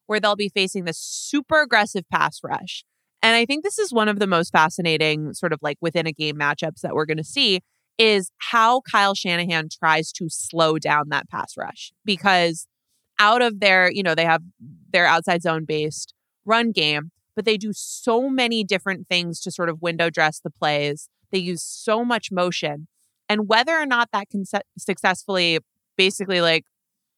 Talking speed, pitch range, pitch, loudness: 185 wpm, 160-210 Hz, 180 Hz, -21 LUFS